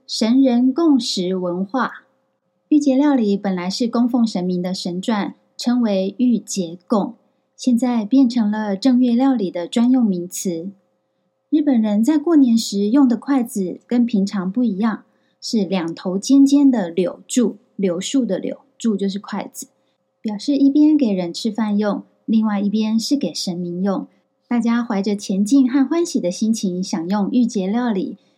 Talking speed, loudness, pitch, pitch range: 230 characters per minute, -19 LUFS, 225 Hz, 195-260 Hz